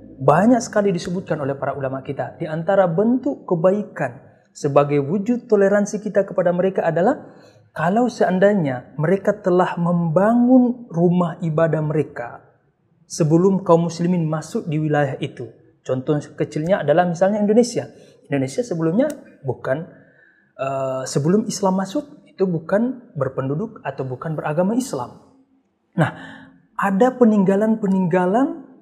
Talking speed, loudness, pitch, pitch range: 115 wpm, -20 LUFS, 180 Hz, 155-210 Hz